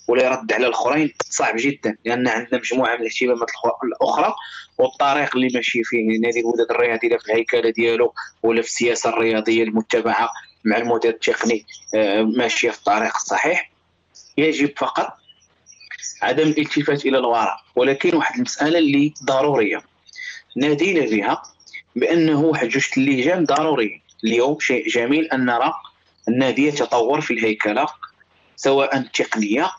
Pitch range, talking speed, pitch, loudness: 115-145 Hz, 125 wpm, 120 Hz, -19 LUFS